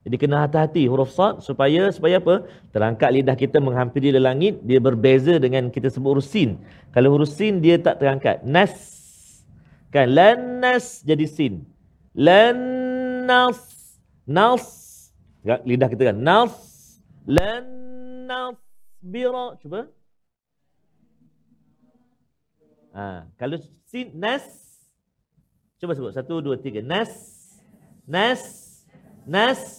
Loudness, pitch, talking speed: -19 LUFS, 170 Hz, 110 wpm